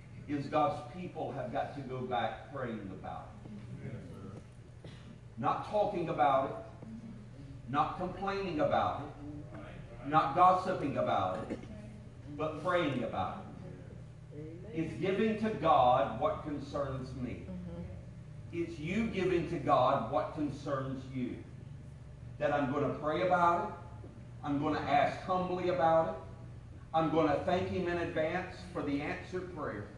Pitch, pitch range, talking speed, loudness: 140 Hz, 120-160 Hz, 135 wpm, -33 LUFS